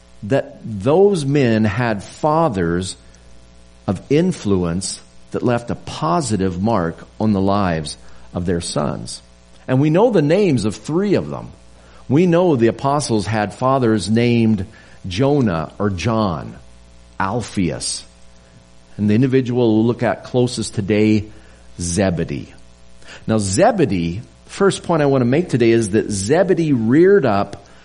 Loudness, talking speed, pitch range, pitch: -17 LUFS, 130 wpm, 80-125 Hz, 105 Hz